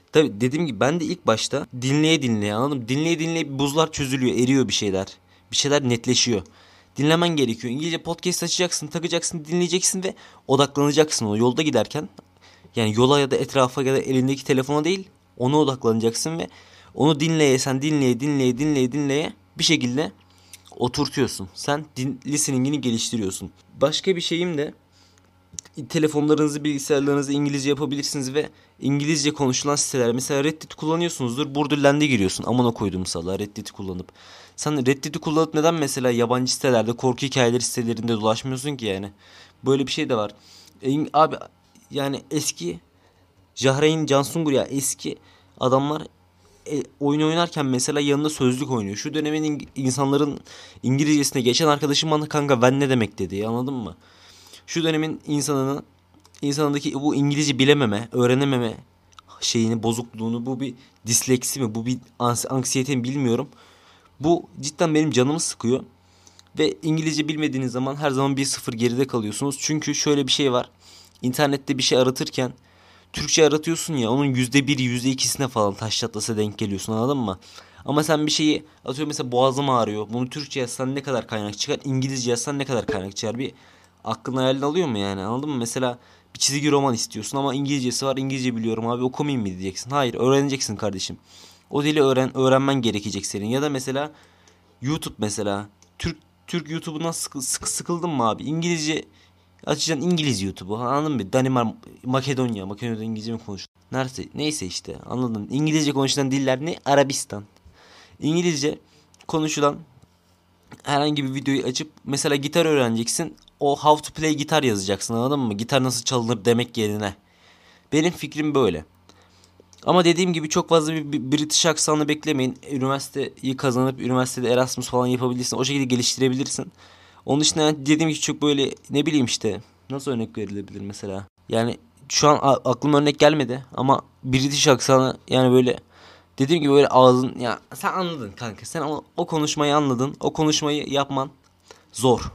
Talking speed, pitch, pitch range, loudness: 150 wpm, 130 Hz, 115-150 Hz, -22 LUFS